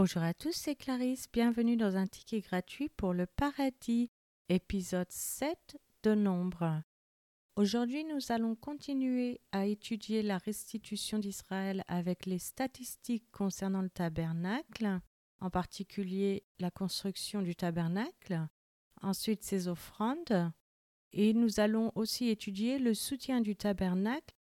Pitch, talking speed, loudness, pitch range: 205 Hz, 125 wpm, -35 LUFS, 185-235 Hz